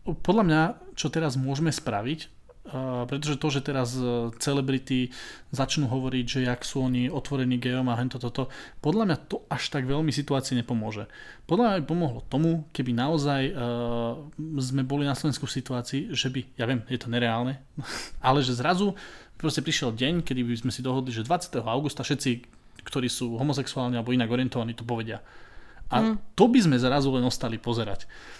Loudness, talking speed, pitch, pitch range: -27 LUFS, 175 wpm, 130 Hz, 125-145 Hz